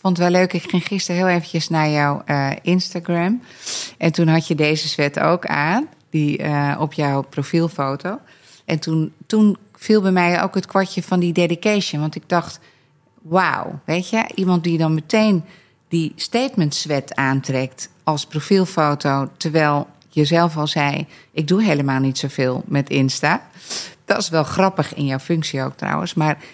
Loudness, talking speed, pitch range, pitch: -19 LUFS, 170 wpm, 145-185 Hz, 165 Hz